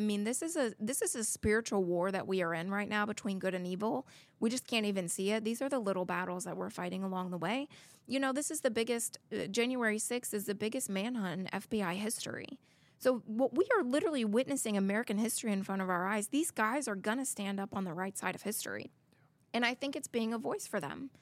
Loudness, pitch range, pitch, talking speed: -35 LUFS, 195-245 Hz, 215 Hz, 245 wpm